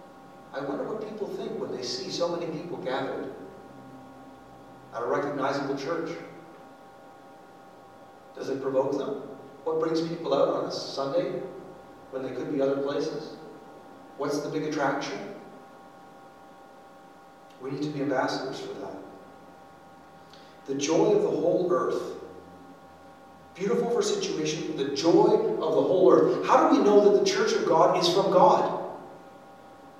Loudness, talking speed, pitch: -26 LUFS, 145 wpm, 155 Hz